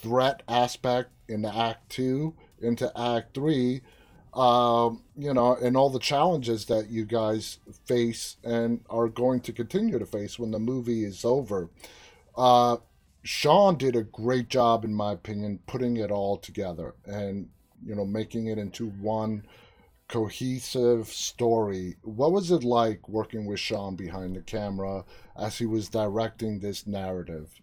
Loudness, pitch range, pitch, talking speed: -27 LUFS, 105-125 Hz, 115 Hz, 150 wpm